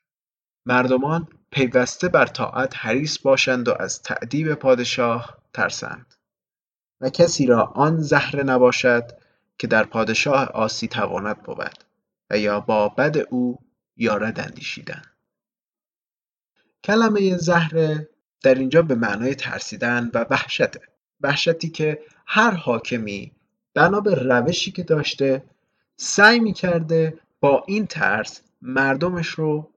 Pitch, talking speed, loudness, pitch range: 140 Hz, 110 wpm, -20 LUFS, 125-165 Hz